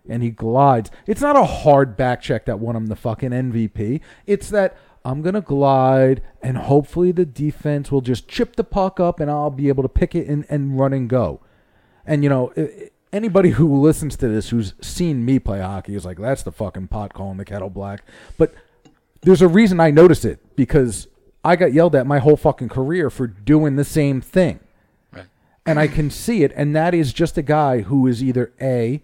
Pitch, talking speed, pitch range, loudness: 140 Hz, 210 wpm, 120-160 Hz, -18 LUFS